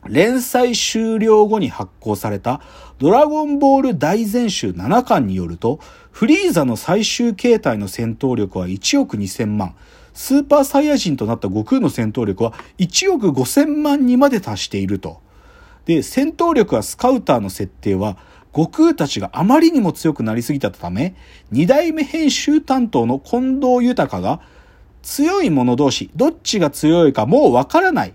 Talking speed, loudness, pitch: 290 characters per minute, -16 LUFS, 170 Hz